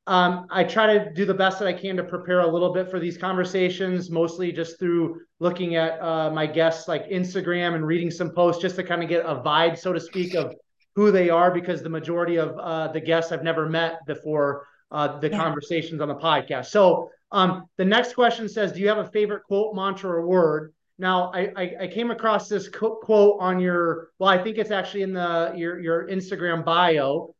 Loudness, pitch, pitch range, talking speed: -23 LUFS, 180 Hz, 165-190 Hz, 215 wpm